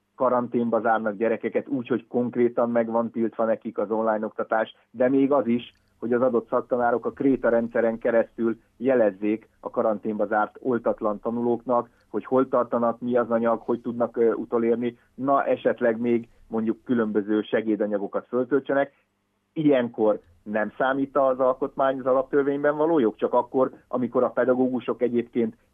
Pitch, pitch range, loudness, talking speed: 120 Hz, 110-130 Hz, -24 LUFS, 145 wpm